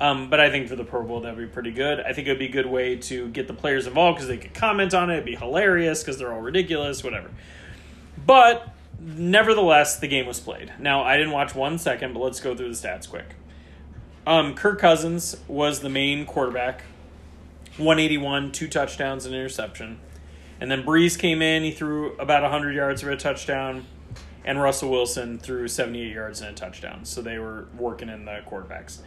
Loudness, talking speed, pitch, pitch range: -23 LUFS, 205 wpm, 135 Hz, 120-150 Hz